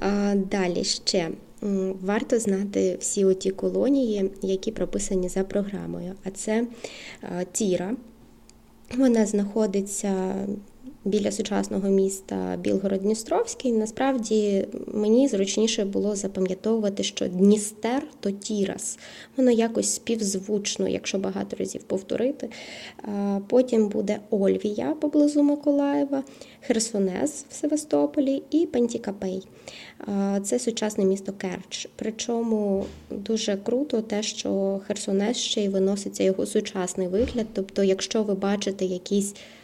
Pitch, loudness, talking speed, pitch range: 210 Hz, -25 LUFS, 100 wpm, 195-235 Hz